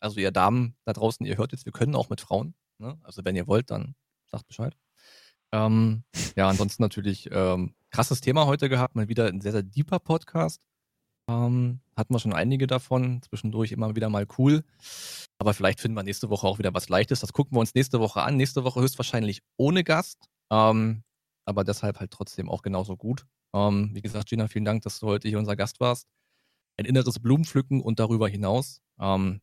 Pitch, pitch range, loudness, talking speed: 110 Hz, 100-130 Hz, -26 LUFS, 200 wpm